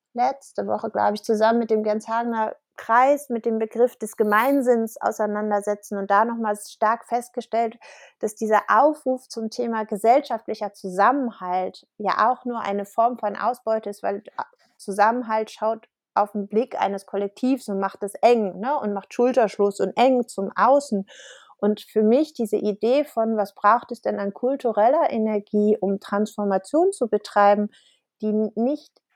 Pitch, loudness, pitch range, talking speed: 220 Hz, -23 LUFS, 205-245 Hz, 155 wpm